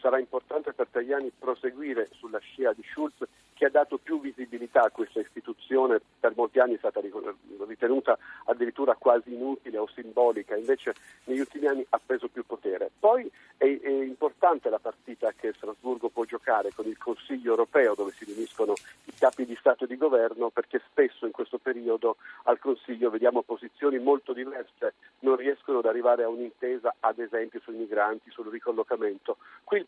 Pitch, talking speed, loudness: 155 Hz, 170 wpm, -28 LUFS